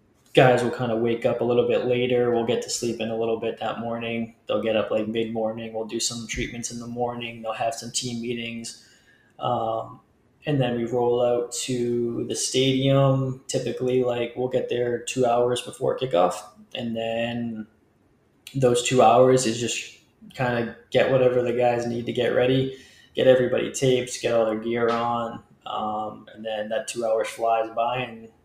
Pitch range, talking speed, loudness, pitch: 115-125 Hz, 190 wpm, -24 LUFS, 120 Hz